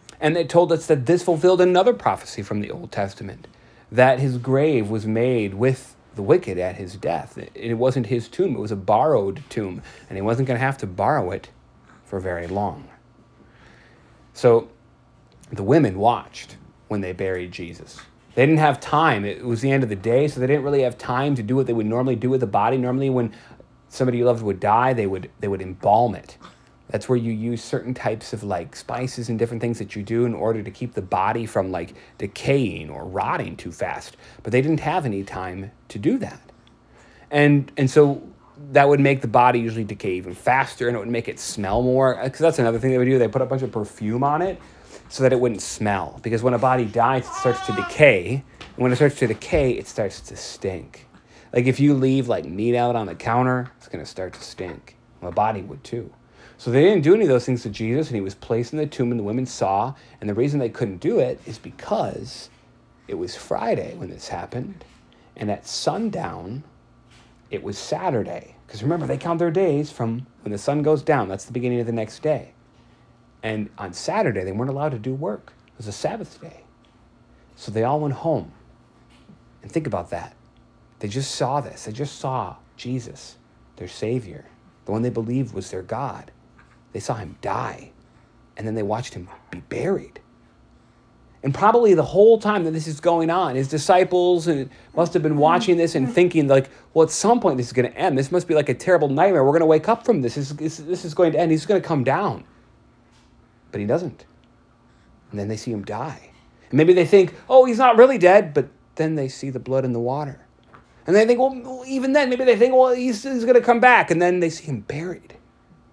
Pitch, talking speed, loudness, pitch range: 125 Hz, 220 wpm, -21 LUFS, 115-155 Hz